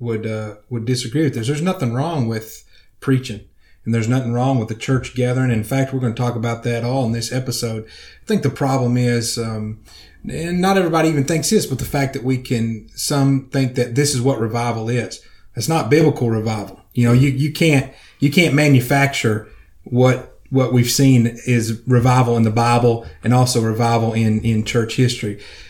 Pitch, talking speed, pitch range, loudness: 125 Hz, 200 wpm, 115-135 Hz, -18 LUFS